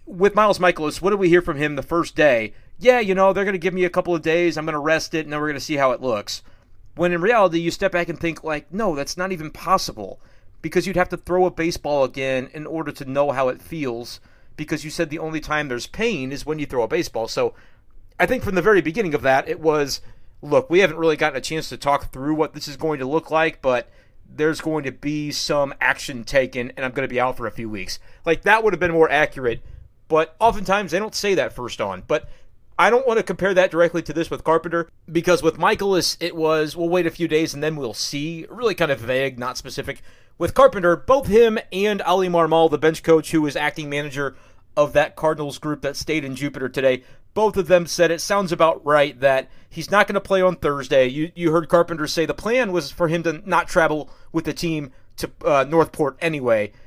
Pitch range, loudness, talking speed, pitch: 140-175 Hz, -21 LUFS, 245 wpm, 160 Hz